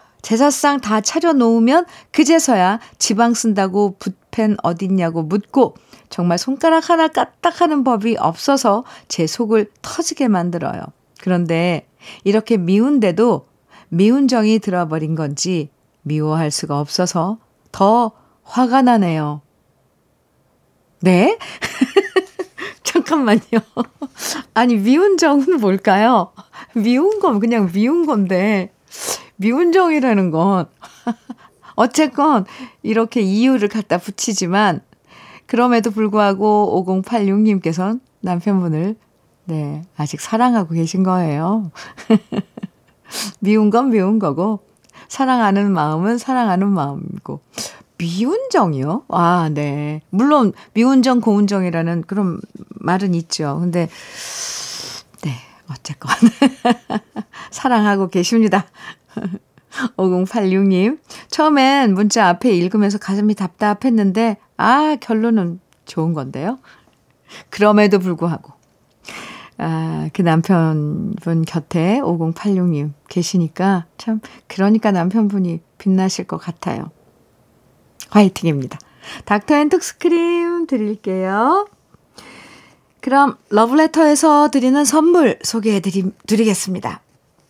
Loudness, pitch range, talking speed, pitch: -16 LUFS, 180-240 Hz, 220 characters per minute, 210 Hz